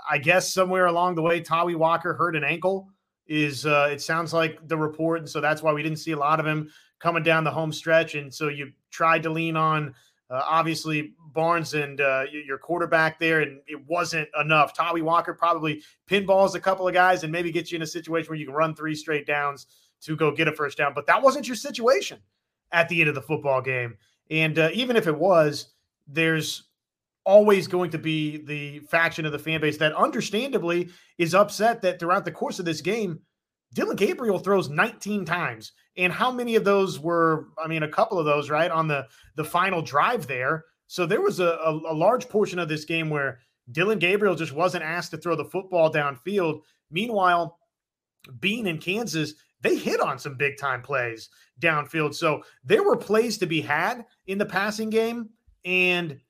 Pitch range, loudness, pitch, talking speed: 150-180 Hz, -24 LUFS, 165 Hz, 205 wpm